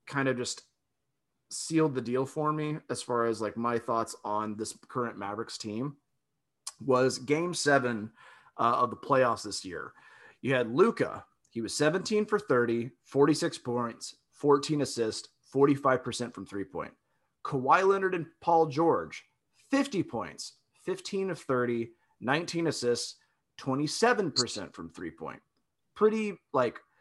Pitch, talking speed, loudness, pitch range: 140 Hz, 140 wpm, -30 LUFS, 120-160 Hz